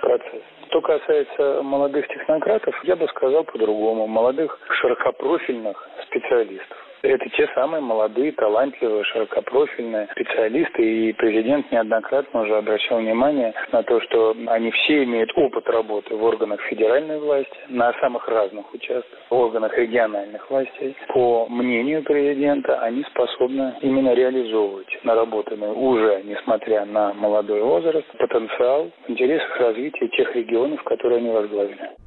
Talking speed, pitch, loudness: 125 wpm, 135 Hz, -21 LUFS